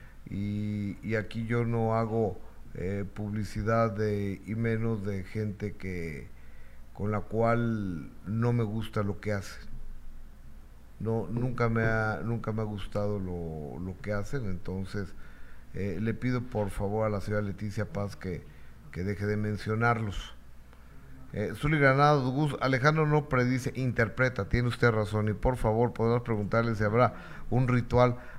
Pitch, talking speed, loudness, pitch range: 105 Hz, 150 wpm, -30 LUFS, 95-115 Hz